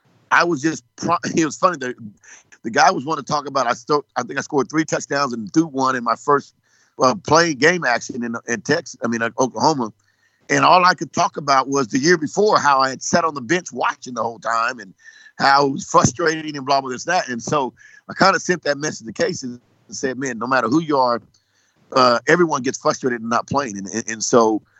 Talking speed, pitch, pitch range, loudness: 235 wpm, 140 Hz, 125-165 Hz, -19 LUFS